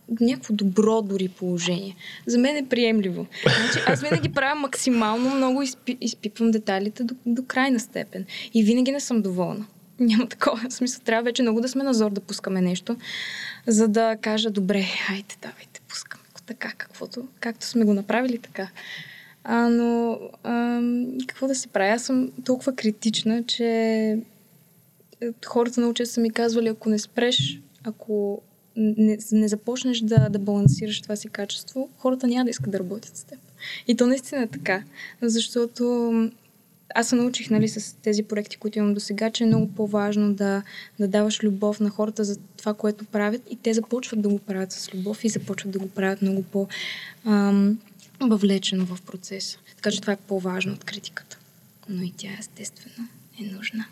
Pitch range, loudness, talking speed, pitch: 200-235 Hz, -24 LUFS, 170 wpm, 215 Hz